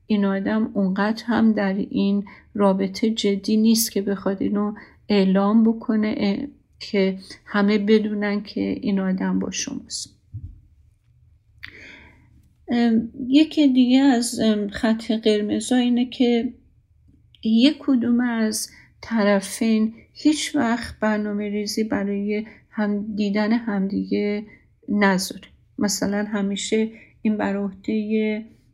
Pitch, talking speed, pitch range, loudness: 210 Hz, 100 wpm, 200-225 Hz, -22 LUFS